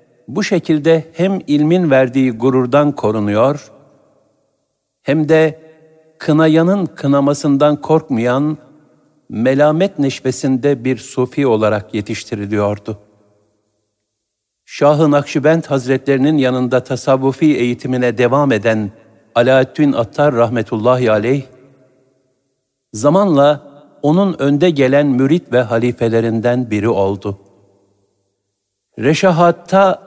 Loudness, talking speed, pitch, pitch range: -14 LUFS, 80 wpm, 130 Hz, 115-150 Hz